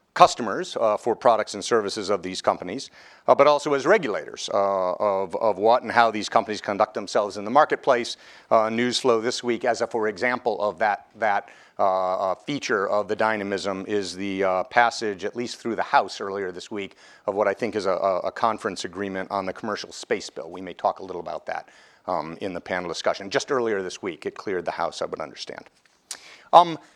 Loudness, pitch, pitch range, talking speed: -24 LUFS, 105 Hz, 95-120 Hz, 210 wpm